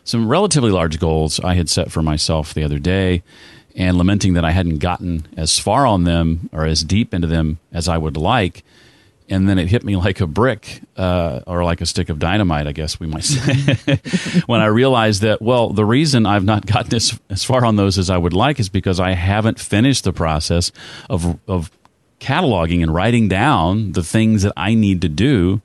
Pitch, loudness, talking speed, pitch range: 95 Hz, -17 LUFS, 210 wpm, 85-110 Hz